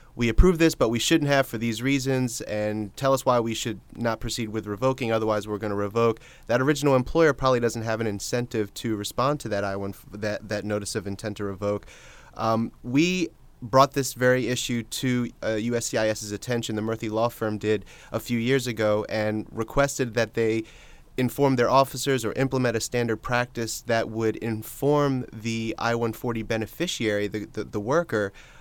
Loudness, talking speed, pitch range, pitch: -25 LUFS, 185 wpm, 110-130 Hz, 115 Hz